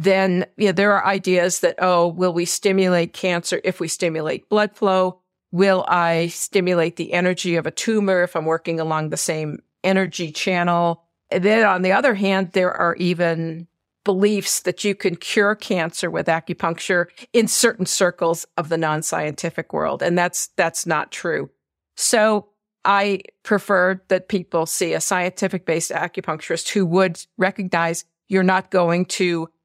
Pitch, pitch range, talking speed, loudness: 180 Hz, 170-195 Hz, 160 wpm, -20 LUFS